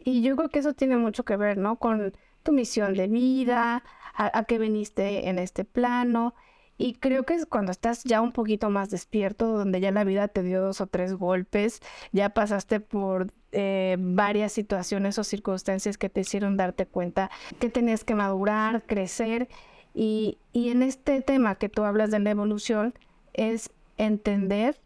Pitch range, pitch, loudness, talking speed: 195-235 Hz, 215 Hz, -27 LUFS, 180 wpm